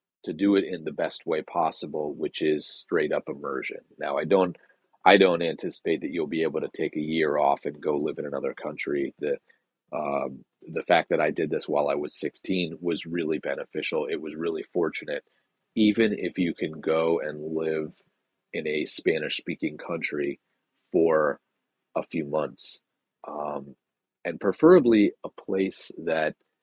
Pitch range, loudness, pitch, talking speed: 75-100 Hz, -27 LUFS, 85 Hz, 170 wpm